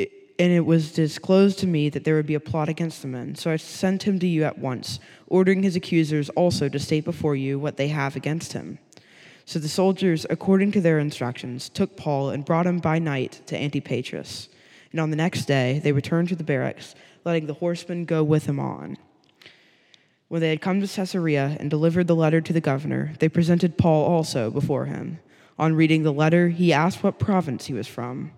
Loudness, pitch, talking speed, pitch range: -23 LUFS, 160 Hz, 210 wpm, 145-175 Hz